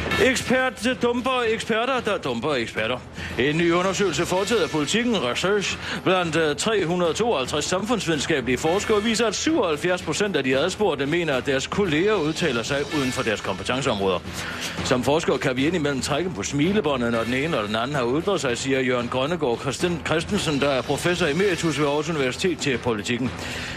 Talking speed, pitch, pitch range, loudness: 165 wpm, 160 Hz, 135-200 Hz, -23 LUFS